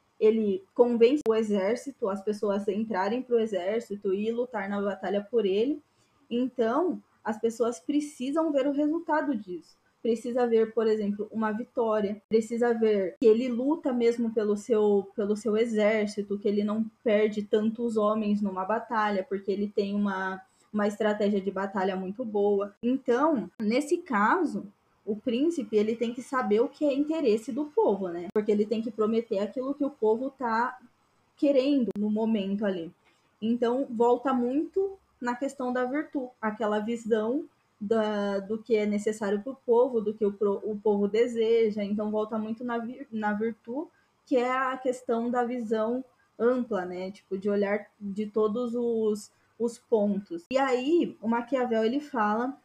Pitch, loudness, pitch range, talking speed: 225 Hz, -28 LUFS, 210-250 Hz, 160 wpm